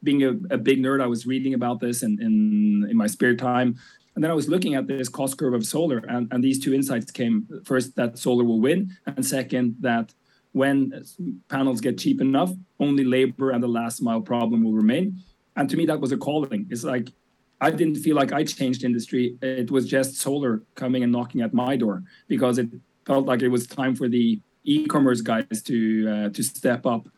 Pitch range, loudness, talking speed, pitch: 120-140 Hz, -23 LUFS, 215 wpm, 130 Hz